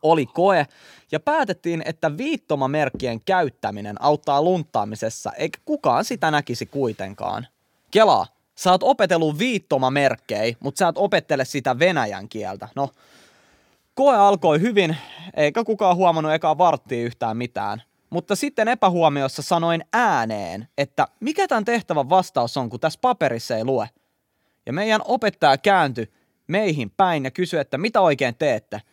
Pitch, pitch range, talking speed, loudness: 160 Hz, 130-205 Hz, 135 wpm, -21 LUFS